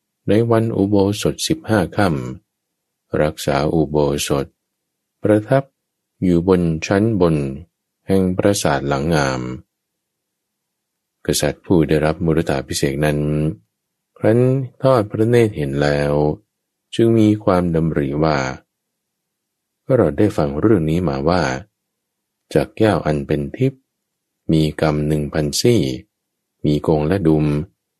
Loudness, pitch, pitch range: -18 LUFS, 80 Hz, 75-105 Hz